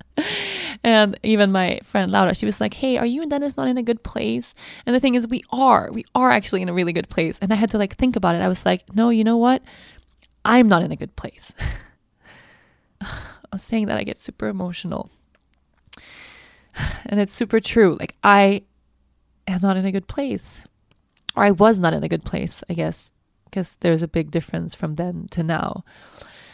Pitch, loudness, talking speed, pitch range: 200 Hz, -20 LUFS, 210 wpm, 175-235 Hz